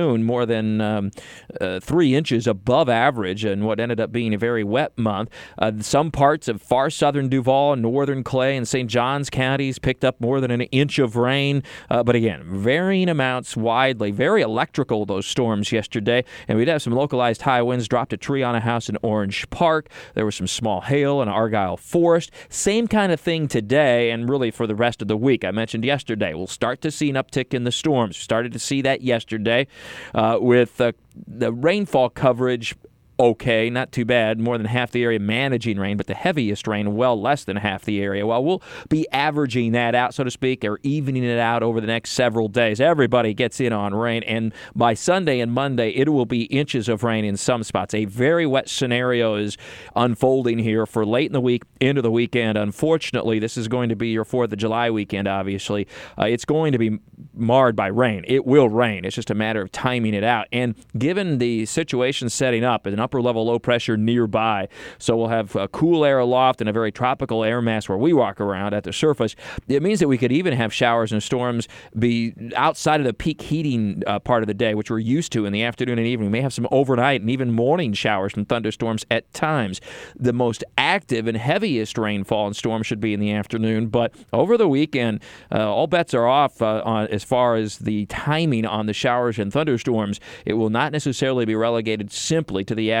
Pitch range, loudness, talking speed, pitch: 110-130 Hz, -21 LUFS, 215 wpm, 120 Hz